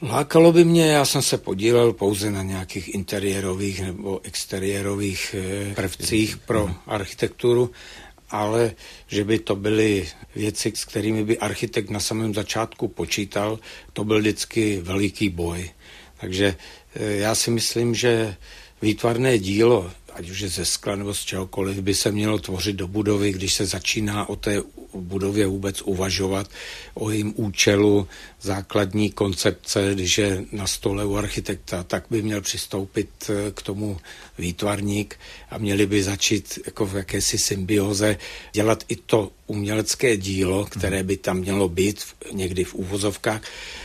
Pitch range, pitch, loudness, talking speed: 95-110 Hz, 100 Hz, -23 LUFS, 140 wpm